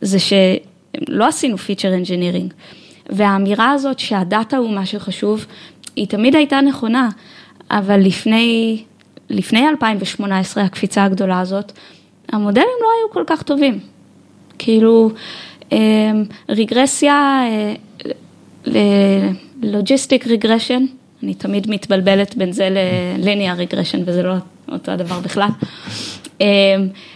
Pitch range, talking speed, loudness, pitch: 190-235 Hz, 95 wpm, -16 LUFS, 205 Hz